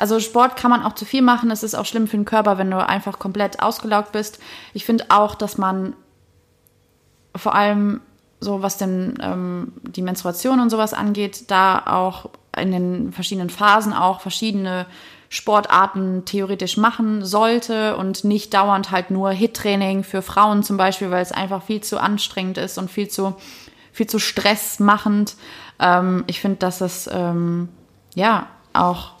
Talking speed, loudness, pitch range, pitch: 165 wpm, -19 LUFS, 190-215 Hz, 205 Hz